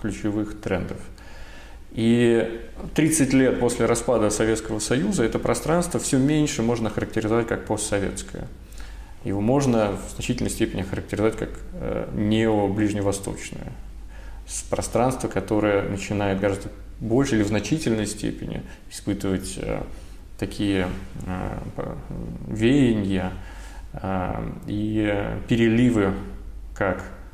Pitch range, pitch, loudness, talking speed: 95-115 Hz, 105 Hz, -24 LUFS, 90 wpm